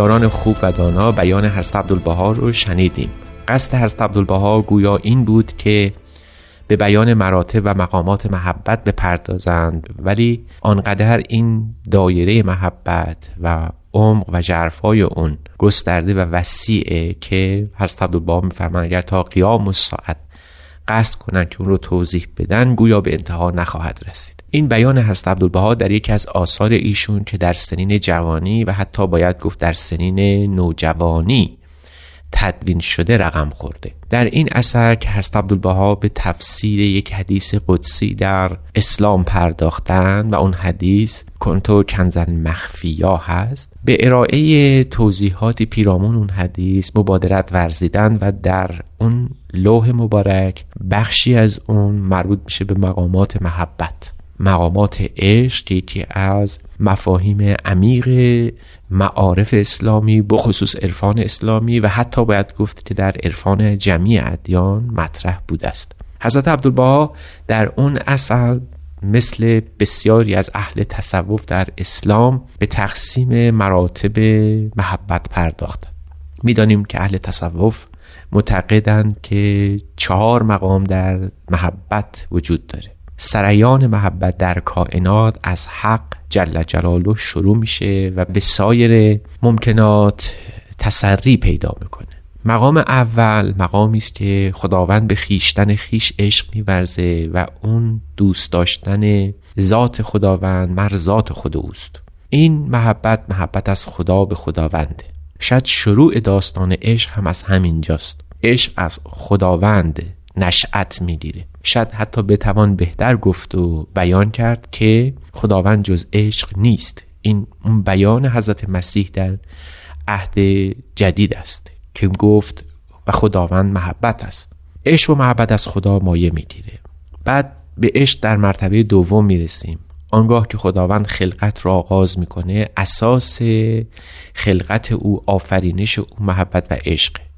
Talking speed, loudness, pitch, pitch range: 125 wpm, -15 LUFS, 100 Hz, 90-110 Hz